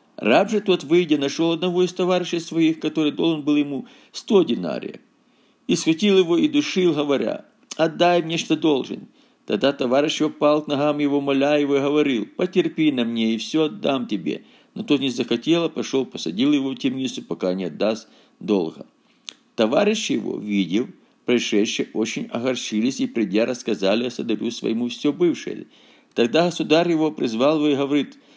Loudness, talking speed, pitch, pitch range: -21 LUFS, 165 wpm, 150 Hz, 125-165 Hz